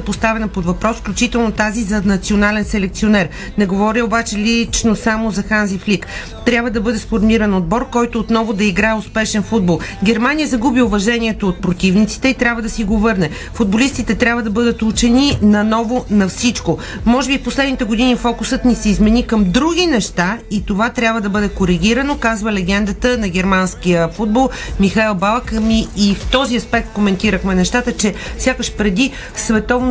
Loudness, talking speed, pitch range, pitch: -15 LUFS, 165 wpm, 205-235 Hz, 220 Hz